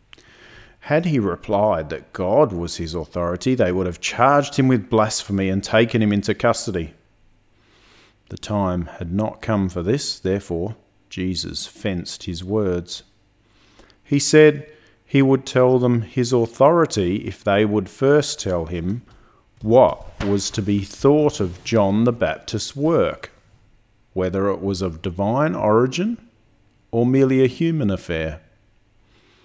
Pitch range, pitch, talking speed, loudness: 95-120 Hz, 110 Hz, 135 wpm, -20 LUFS